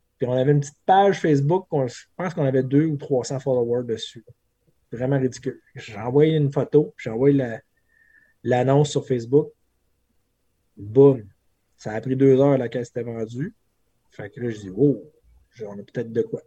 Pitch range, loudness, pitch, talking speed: 115-145 Hz, -22 LUFS, 130 Hz, 180 wpm